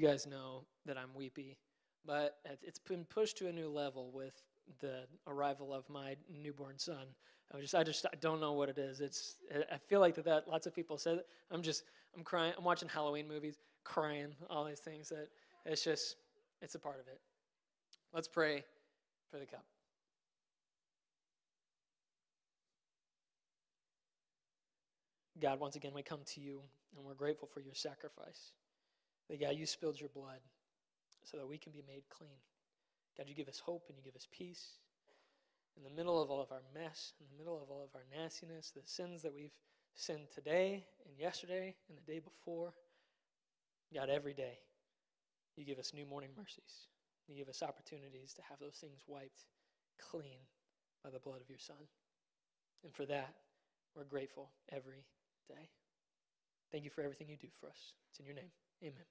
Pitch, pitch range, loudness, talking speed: 150 Hz, 140-165 Hz, -43 LUFS, 175 wpm